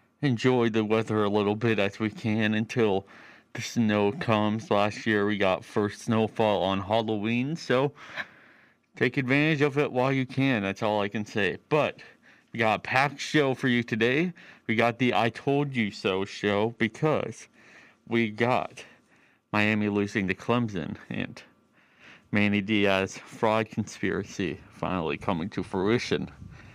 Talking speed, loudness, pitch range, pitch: 150 wpm, -27 LUFS, 105-125 Hz, 110 Hz